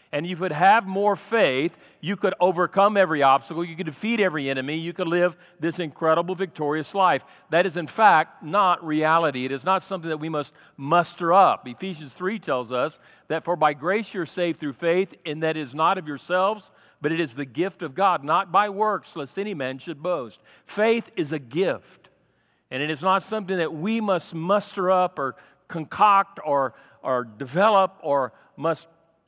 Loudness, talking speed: -23 LUFS, 190 wpm